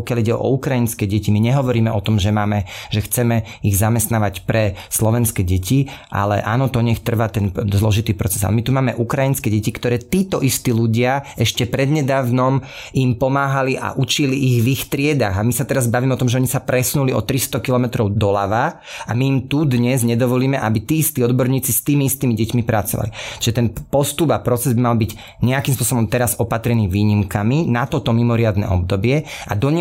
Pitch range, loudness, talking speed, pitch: 110-135 Hz, -18 LUFS, 190 wpm, 120 Hz